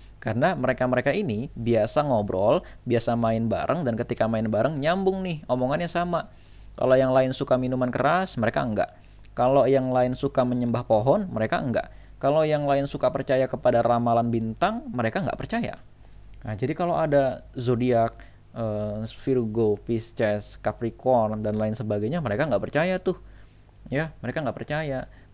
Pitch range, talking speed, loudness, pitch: 110-135 Hz, 150 wpm, -25 LUFS, 120 Hz